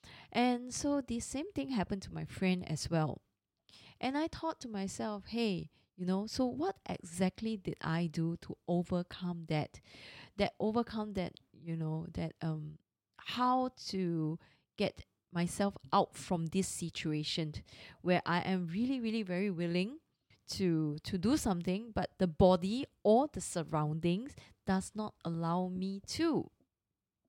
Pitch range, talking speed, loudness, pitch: 165-220 Hz, 145 wpm, -36 LUFS, 185 Hz